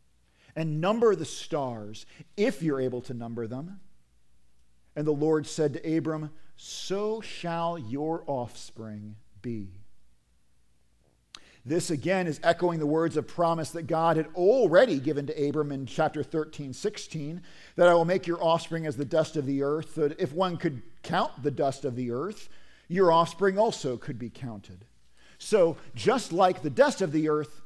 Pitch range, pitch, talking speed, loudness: 125-170 Hz, 155 Hz, 165 wpm, -28 LUFS